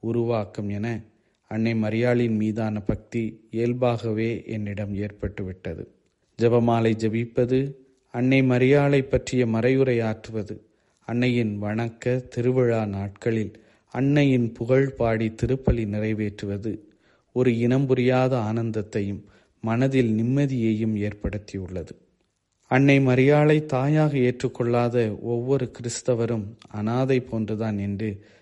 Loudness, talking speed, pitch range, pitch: -24 LUFS, 80 wpm, 110-125 Hz, 115 Hz